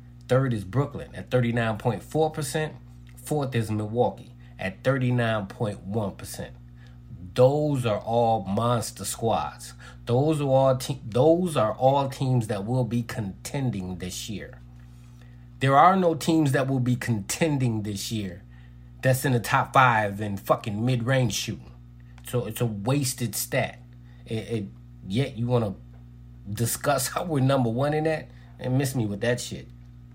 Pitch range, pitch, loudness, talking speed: 100-130 Hz, 120 Hz, -25 LUFS, 160 wpm